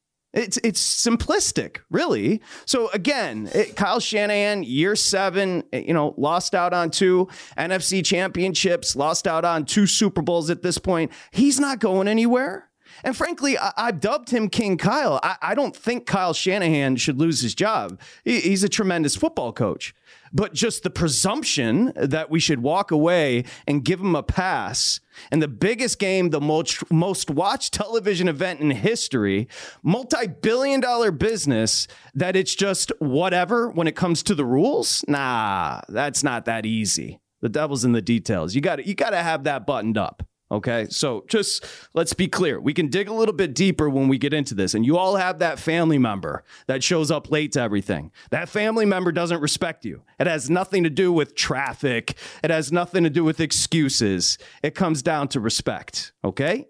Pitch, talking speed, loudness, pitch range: 175 Hz, 180 wpm, -22 LUFS, 150-205 Hz